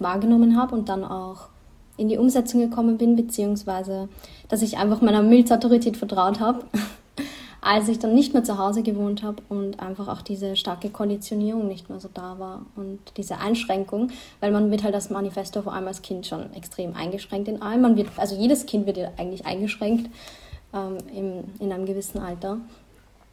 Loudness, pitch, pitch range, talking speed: -23 LUFS, 205 Hz, 195-230 Hz, 175 wpm